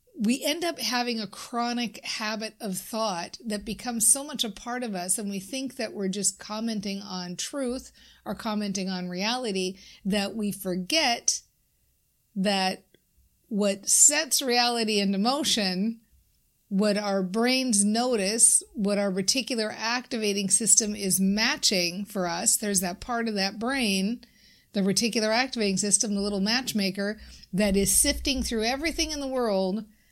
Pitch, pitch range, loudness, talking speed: 215 Hz, 200-240 Hz, -25 LUFS, 145 wpm